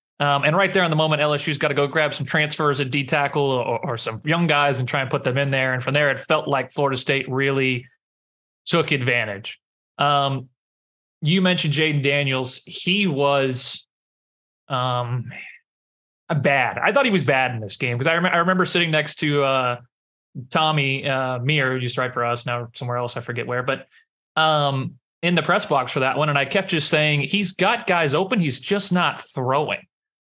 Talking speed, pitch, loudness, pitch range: 205 wpm, 140 Hz, -21 LUFS, 130-155 Hz